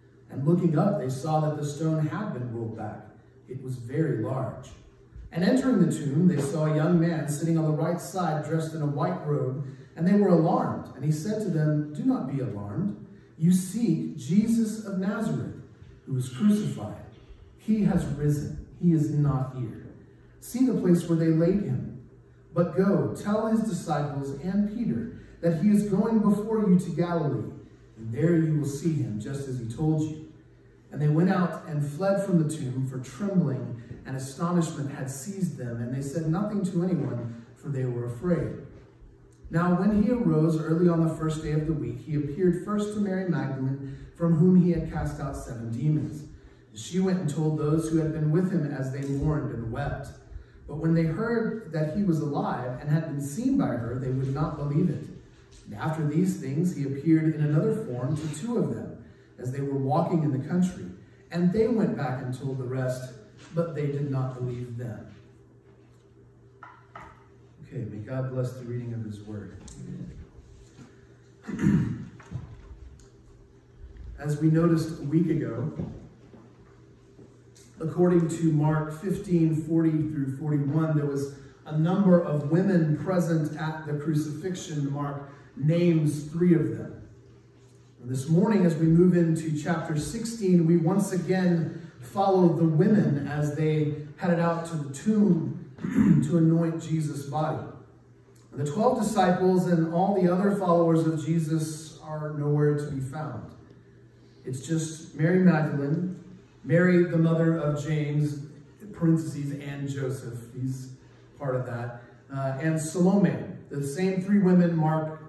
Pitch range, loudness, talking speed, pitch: 135-175 Hz, -26 LUFS, 165 wpm, 155 Hz